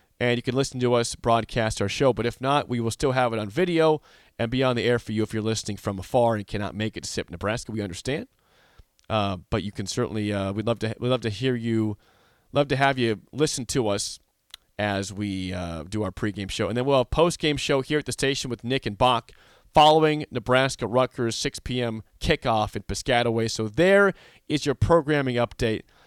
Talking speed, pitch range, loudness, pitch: 225 wpm, 105-135 Hz, -25 LUFS, 115 Hz